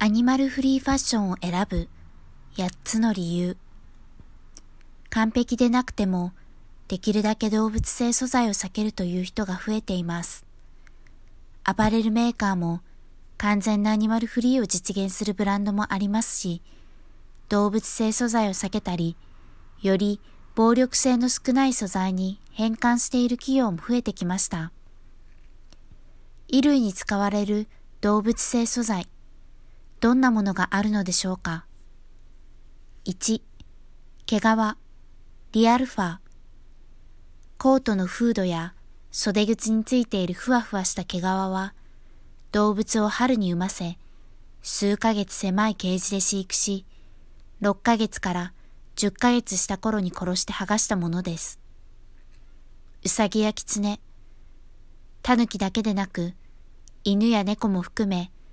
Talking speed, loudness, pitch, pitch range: 250 characters per minute, -23 LUFS, 200 Hz, 170-220 Hz